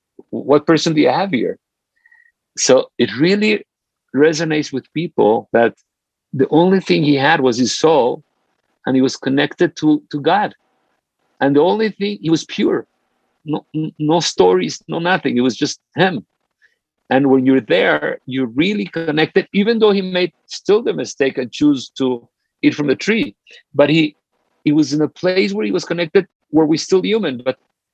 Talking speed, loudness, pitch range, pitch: 175 wpm, -16 LUFS, 135-185 Hz, 155 Hz